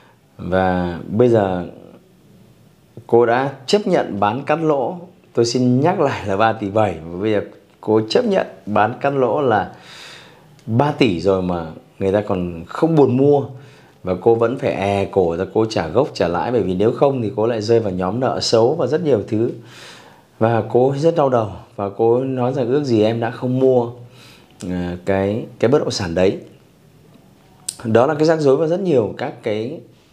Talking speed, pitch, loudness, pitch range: 195 wpm, 115 Hz, -18 LUFS, 100-135 Hz